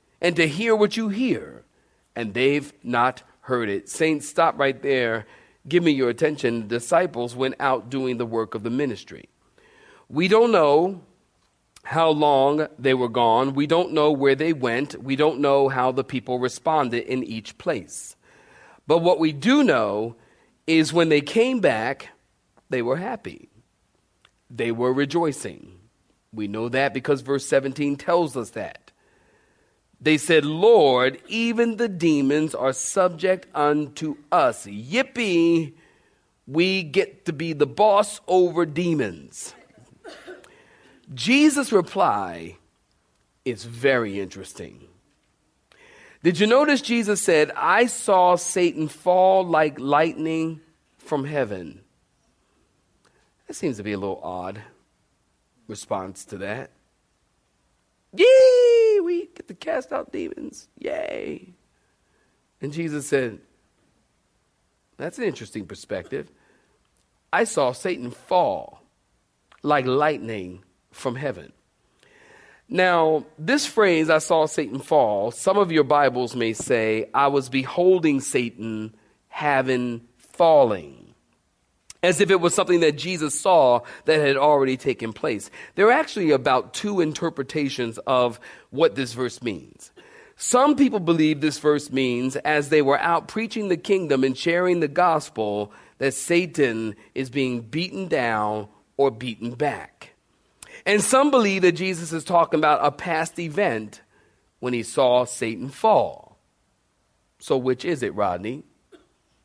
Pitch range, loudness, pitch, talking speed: 125-180 Hz, -22 LUFS, 150 Hz, 130 wpm